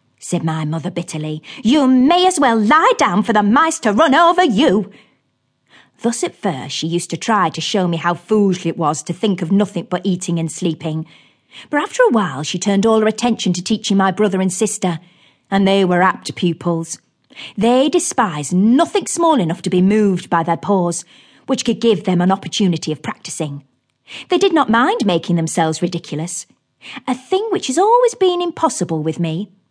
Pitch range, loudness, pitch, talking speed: 170-240 Hz, -16 LUFS, 190 Hz, 190 wpm